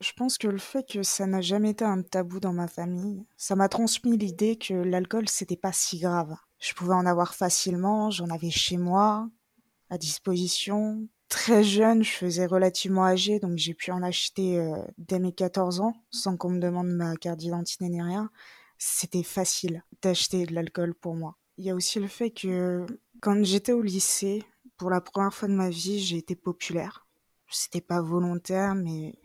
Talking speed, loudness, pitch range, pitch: 190 wpm, -27 LUFS, 180-205 Hz, 185 Hz